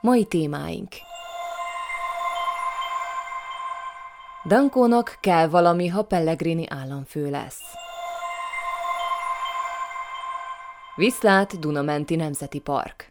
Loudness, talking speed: -24 LUFS, 60 wpm